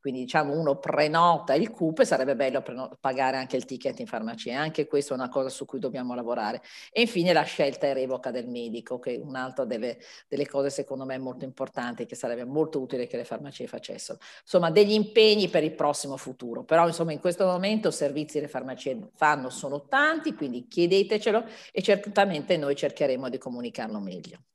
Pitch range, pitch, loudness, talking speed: 130-170 Hz, 140 Hz, -27 LUFS, 195 wpm